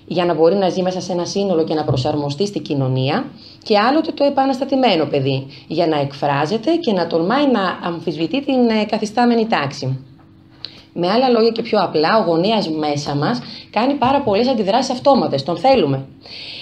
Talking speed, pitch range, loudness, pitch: 170 wpm, 150-235 Hz, -17 LUFS, 180 Hz